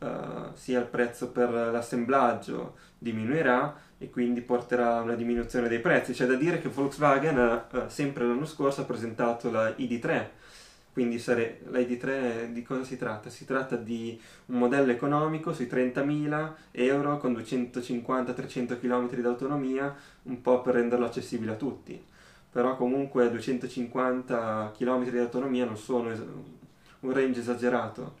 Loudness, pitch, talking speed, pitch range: -29 LUFS, 125 Hz, 150 wpm, 120-130 Hz